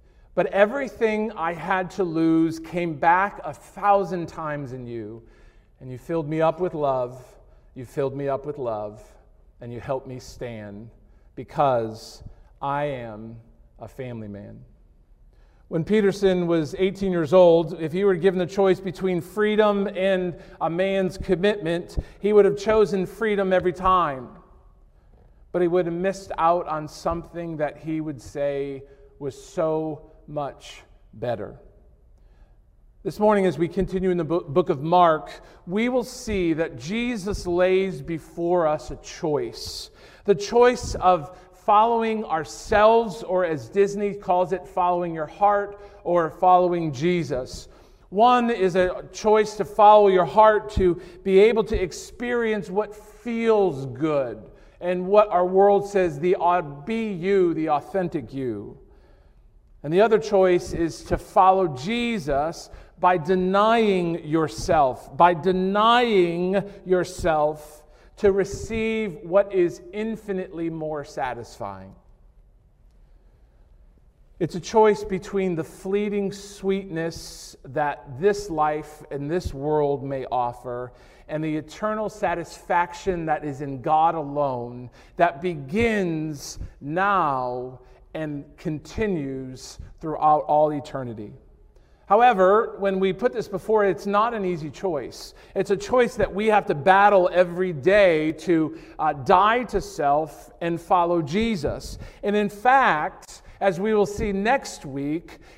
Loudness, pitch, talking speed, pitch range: -23 LUFS, 180 Hz, 135 wpm, 150-200 Hz